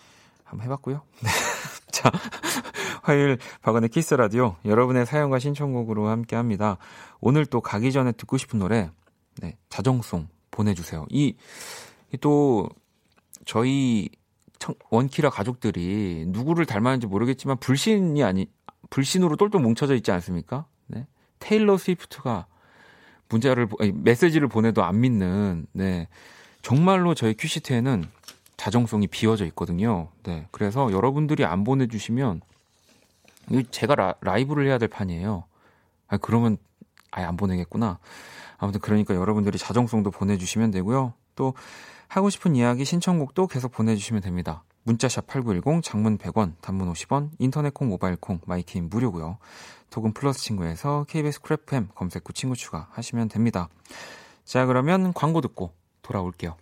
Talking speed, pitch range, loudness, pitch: 315 characters per minute, 100-135 Hz, -24 LUFS, 115 Hz